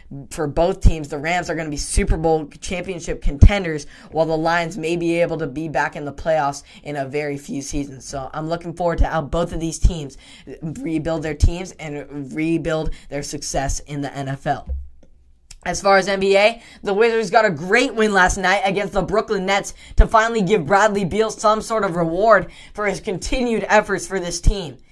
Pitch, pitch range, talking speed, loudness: 170 Hz, 150-200 Hz, 195 wpm, -20 LUFS